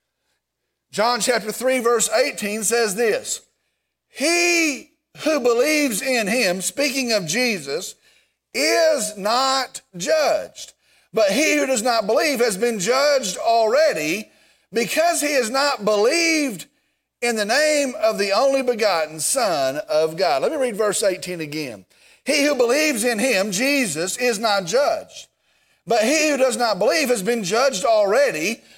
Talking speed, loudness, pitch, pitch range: 140 wpm, -19 LUFS, 250 Hz, 220-295 Hz